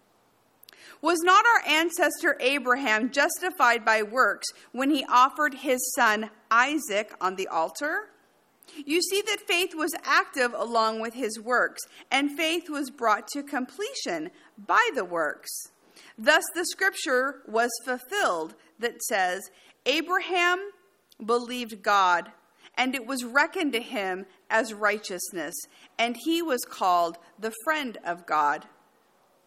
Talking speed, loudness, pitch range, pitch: 125 wpm, -25 LUFS, 225-330 Hz, 260 Hz